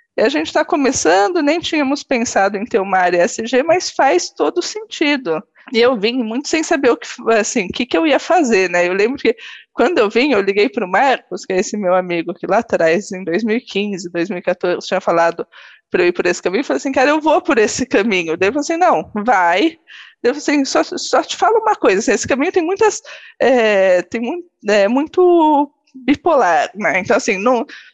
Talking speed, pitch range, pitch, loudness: 210 wpm, 200-330 Hz, 255 Hz, -15 LUFS